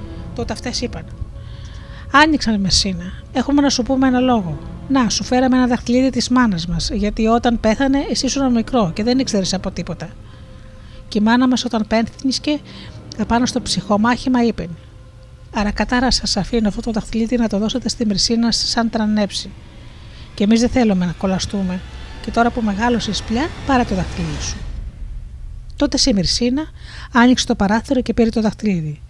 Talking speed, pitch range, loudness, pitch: 165 wpm, 195-250 Hz, -17 LUFS, 225 Hz